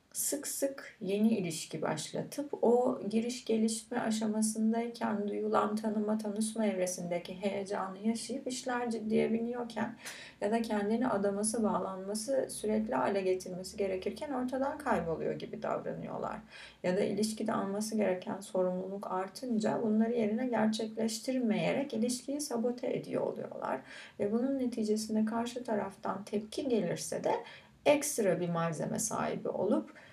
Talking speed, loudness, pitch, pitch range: 115 wpm, -34 LUFS, 220 Hz, 205-240 Hz